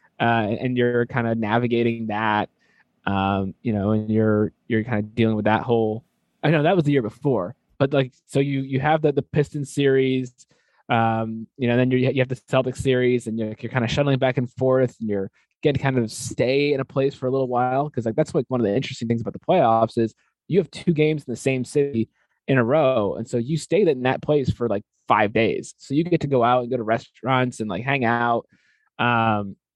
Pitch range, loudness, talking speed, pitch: 115-135 Hz, -22 LUFS, 240 wpm, 125 Hz